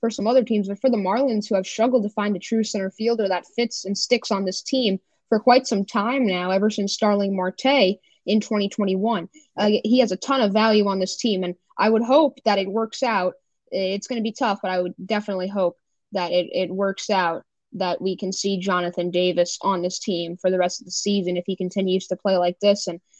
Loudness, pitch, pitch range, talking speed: -22 LUFS, 200 Hz, 185-225 Hz, 235 wpm